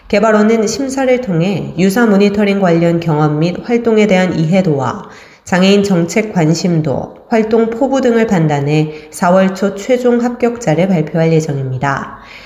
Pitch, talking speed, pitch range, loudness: 190 Hz, 300 characters per minute, 160-225 Hz, -13 LUFS